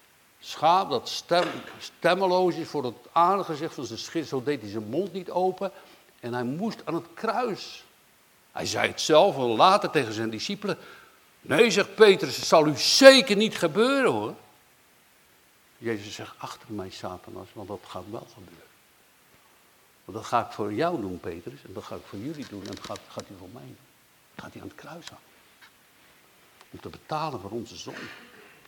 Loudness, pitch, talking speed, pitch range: -24 LUFS, 165 Hz, 185 wpm, 120-195 Hz